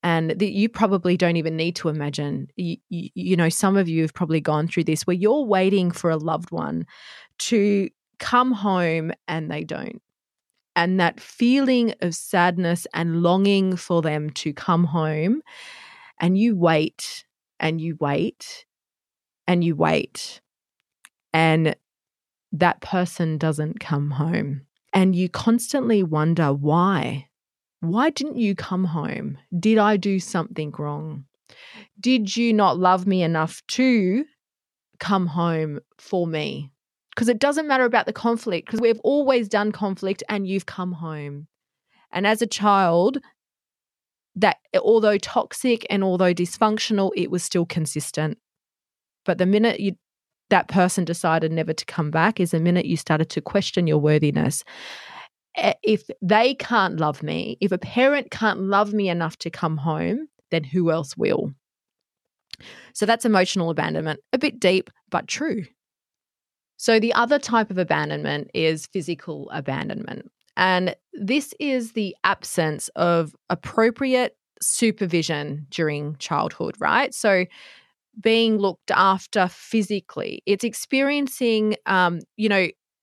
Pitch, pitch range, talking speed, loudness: 185 Hz, 160-220 Hz, 140 wpm, -22 LUFS